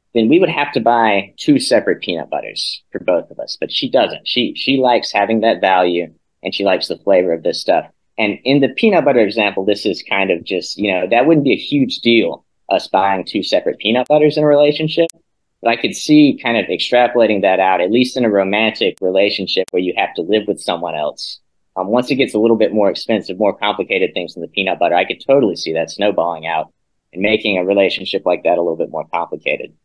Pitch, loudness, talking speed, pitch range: 120 Hz, -15 LUFS, 235 wpm, 100-150 Hz